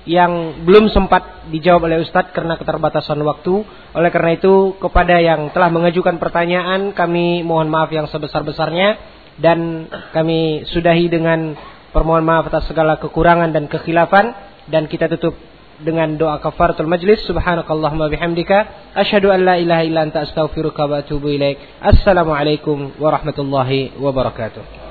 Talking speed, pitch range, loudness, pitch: 130 wpm, 155-175 Hz, -15 LUFS, 165 Hz